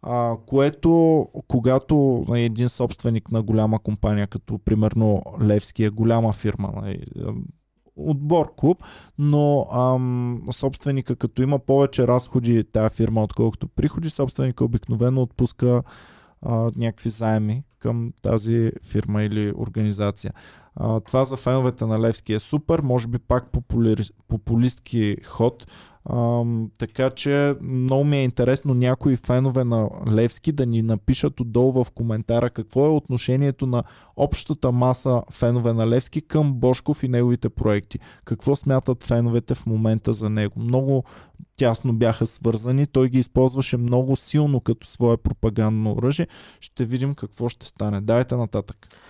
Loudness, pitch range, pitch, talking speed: -22 LUFS, 110-130 Hz, 120 Hz, 135 wpm